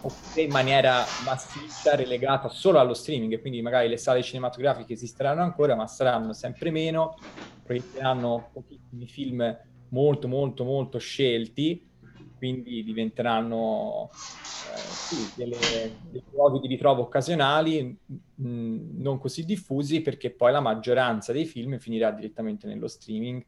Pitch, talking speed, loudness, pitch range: 130 Hz, 125 wpm, -26 LUFS, 120-145 Hz